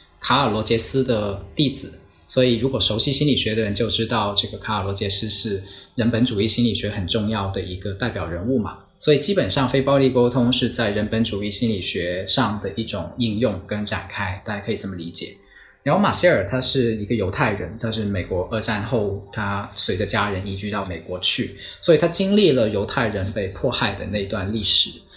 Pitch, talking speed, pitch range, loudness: 110 Hz, 310 characters per minute, 100-120 Hz, -20 LUFS